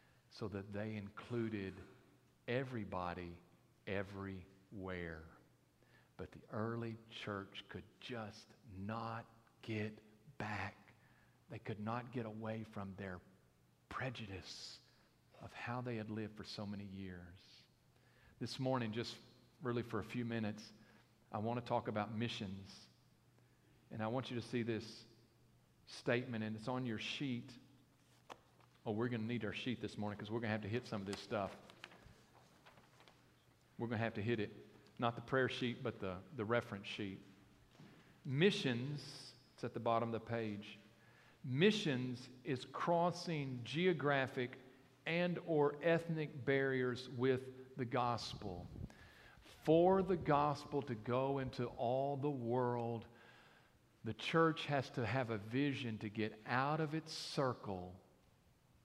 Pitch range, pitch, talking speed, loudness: 105-130 Hz, 120 Hz, 140 wpm, -41 LUFS